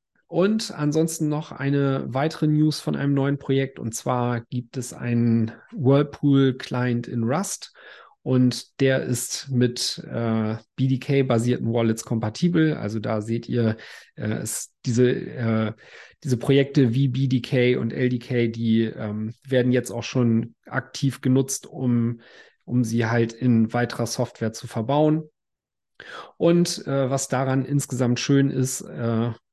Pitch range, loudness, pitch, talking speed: 115-140 Hz, -23 LUFS, 125 Hz, 130 wpm